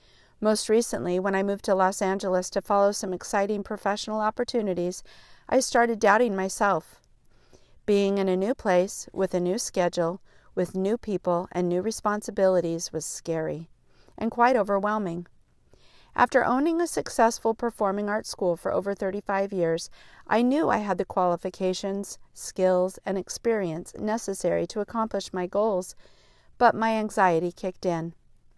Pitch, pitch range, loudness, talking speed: 195 Hz, 180-215 Hz, -26 LUFS, 145 wpm